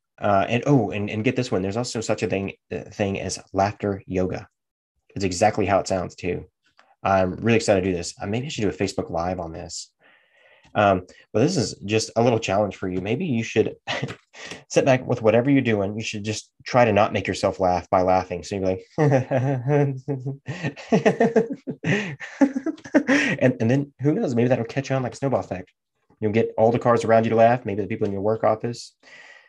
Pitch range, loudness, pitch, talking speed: 100-130 Hz, -23 LUFS, 115 Hz, 205 wpm